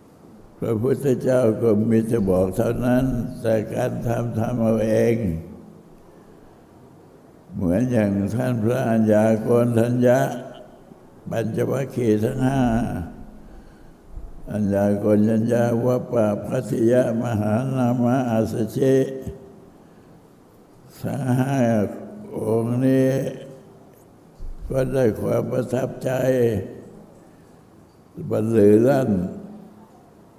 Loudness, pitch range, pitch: -21 LUFS, 110-125 Hz, 120 Hz